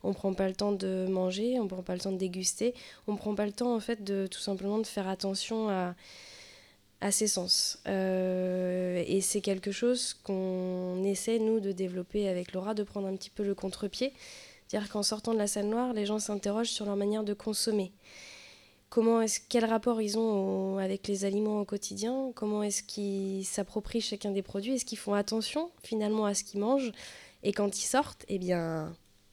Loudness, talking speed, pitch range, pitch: -32 LUFS, 210 wpm, 190-220 Hz, 205 Hz